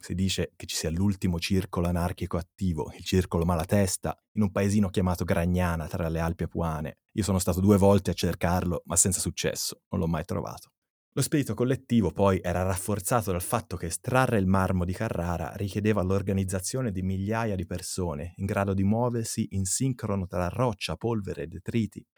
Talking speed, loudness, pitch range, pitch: 180 wpm, -28 LUFS, 90-105 Hz, 95 Hz